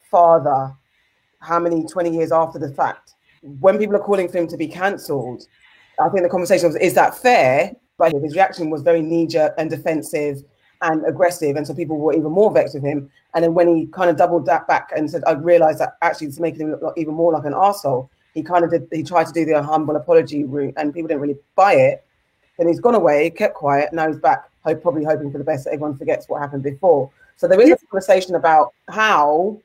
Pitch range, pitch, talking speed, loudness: 155-180 Hz, 165 Hz, 230 wpm, -18 LUFS